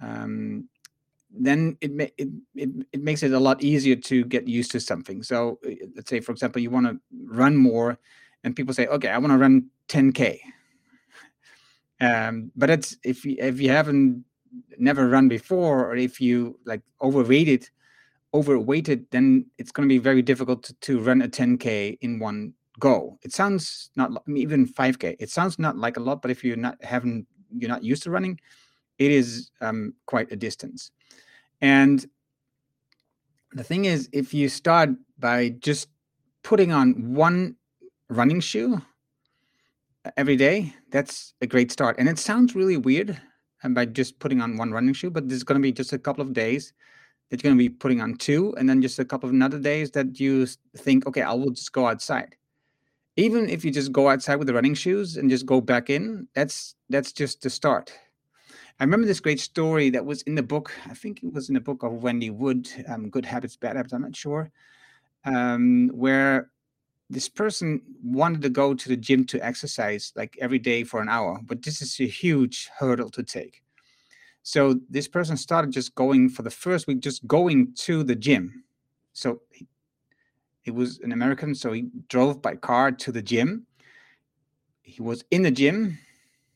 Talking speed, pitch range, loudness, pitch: 190 wpm, 125-150 Hz, -23 LUFS, 135 Hz